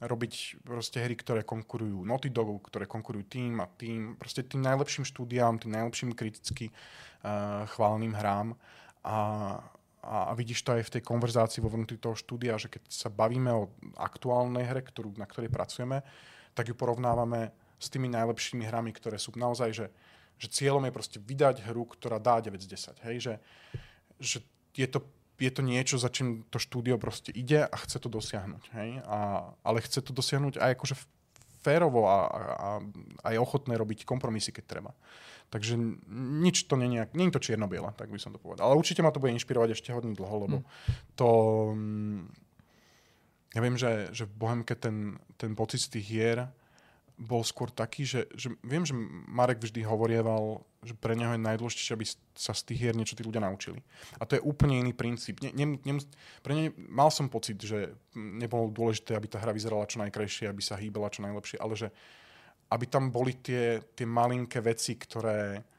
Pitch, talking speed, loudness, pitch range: 115 Hz, 185 wpm, -32 LUFS, 110-125 Hz